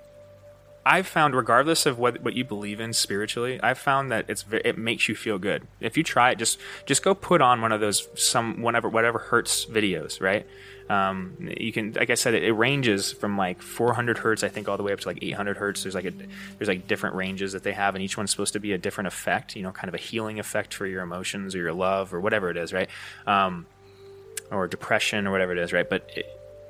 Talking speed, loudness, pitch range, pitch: 240 wpm, -25 LUFS, 95-120 Hz, 105 Hz